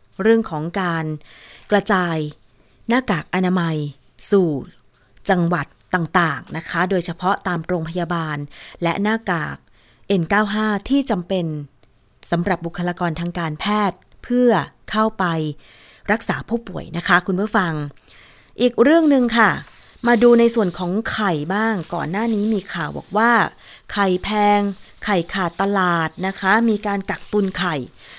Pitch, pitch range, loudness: 185 Hz, 165-210 Hz, -20 LUFS